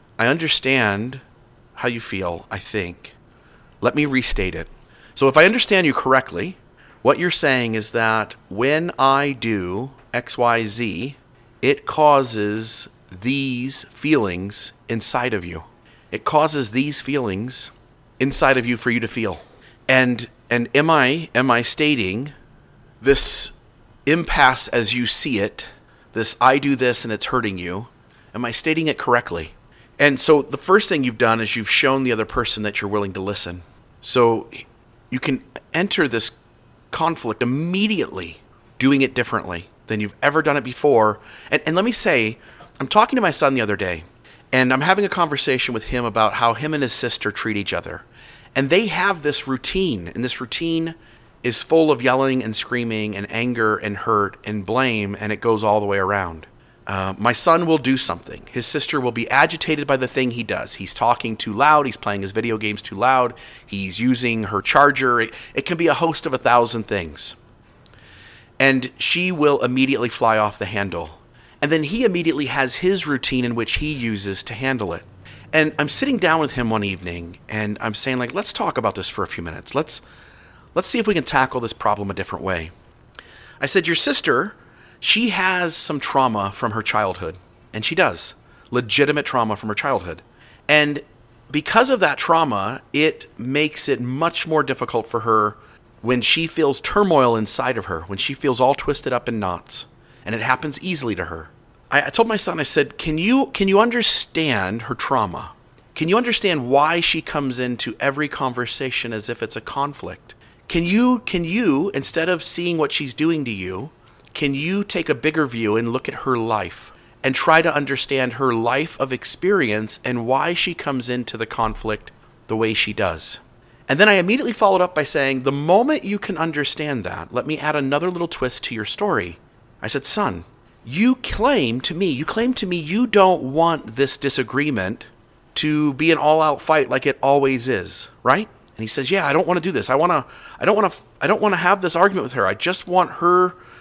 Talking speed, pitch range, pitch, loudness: 190 wpm, 115-150 Hz, 130 Hz, -18 LUFS